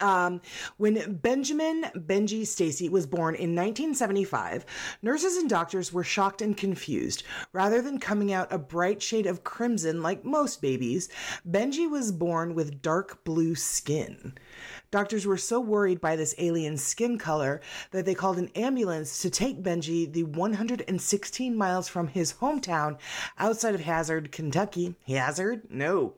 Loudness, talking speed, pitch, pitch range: -28 LUFS, 145 wpm, 190 Hz, 170-220 Hz